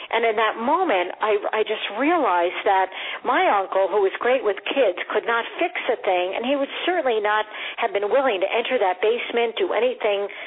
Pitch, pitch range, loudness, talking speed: 215 Hz, 200-245 Hz, -22 LUFS, 200 wpm